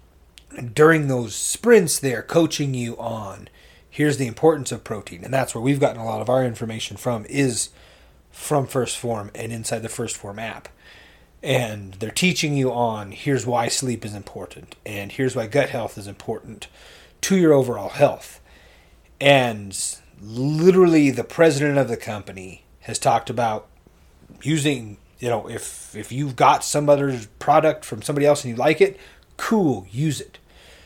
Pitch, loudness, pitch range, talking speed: 120 Hz, -21 LUFS, 105-140 Hz, 165 wpm